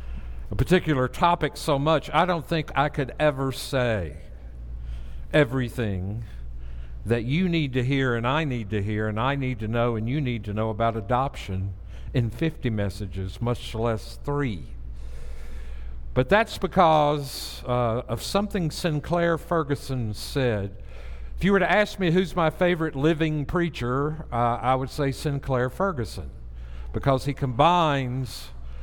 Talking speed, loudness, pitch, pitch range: 145 wpm, -25 LUFS, 125 Hz, 100-150 Hz